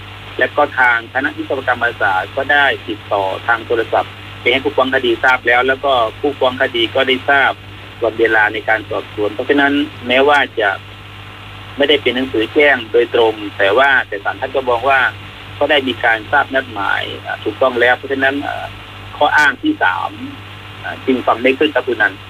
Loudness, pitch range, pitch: -14 LUFS, 105-135 Hz, 125 Hz